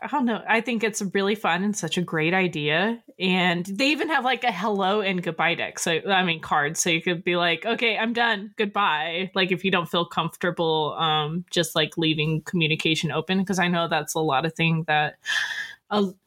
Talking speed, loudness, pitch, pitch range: 215 wpm, -23 LUFS, 180 Hz, 165-210 Hz